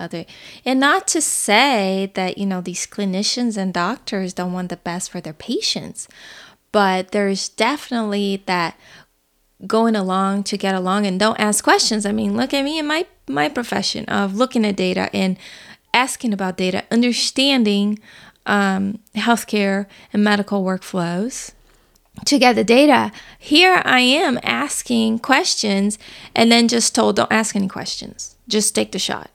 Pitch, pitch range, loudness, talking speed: 205 Hz, 190-240 Hz, -18 LUFS, 155 wpm